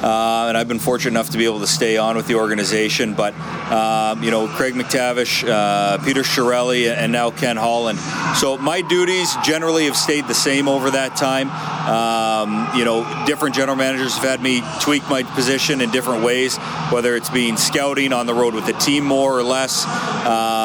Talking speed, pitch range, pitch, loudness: 200 wpm, 115-135 Hz, 125 Hz, -18 LUFS